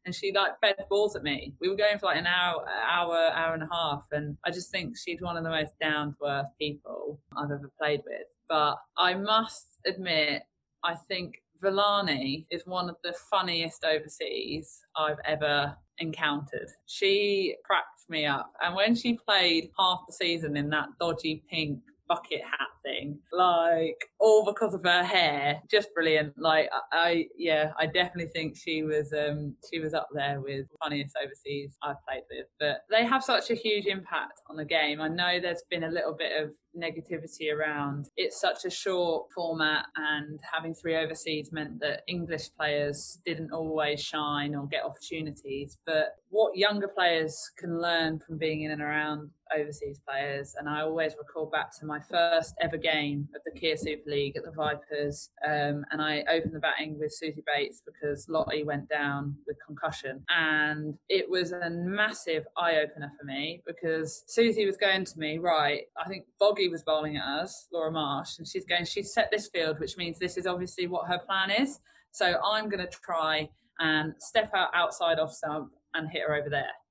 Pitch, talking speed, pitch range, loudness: 160 Hz, 185 wpm, 150-180 Hz, -29 LUFS